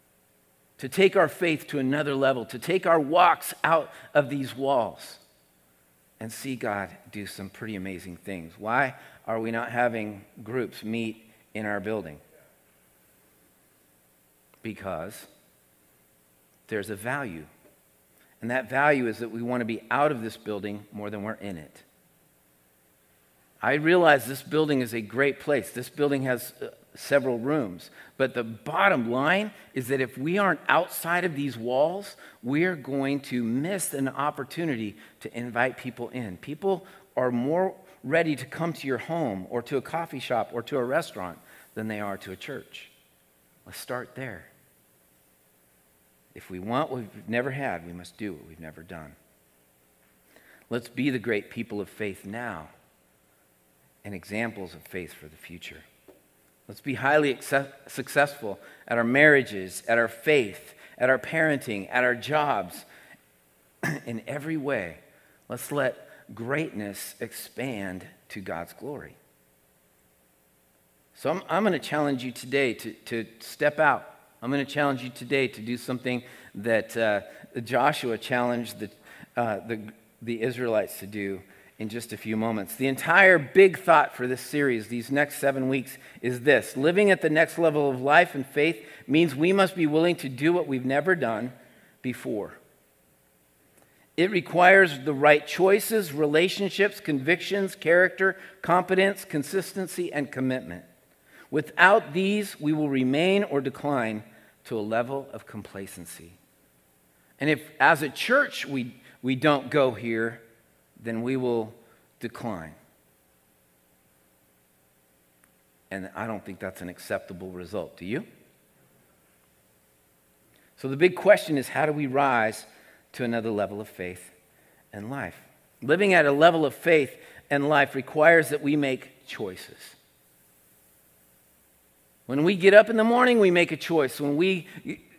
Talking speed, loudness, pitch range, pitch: 150 wpm, -25 LUFS, 90-145 Hz, 120 Hz